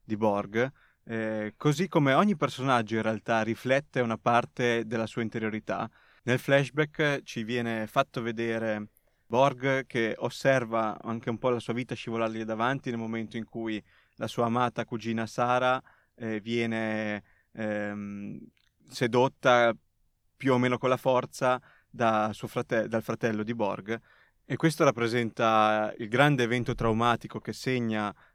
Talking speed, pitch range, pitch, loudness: 140 wpm, 110-125 Hz, 115 Hz, -28 LUFS